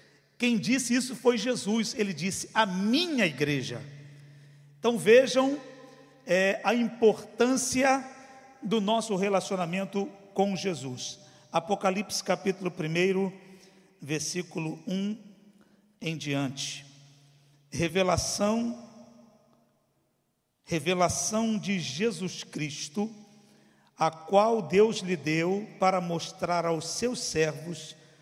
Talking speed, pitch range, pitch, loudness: 90 wpm, 160-220 Hz, 195 Hz, -28 LUFS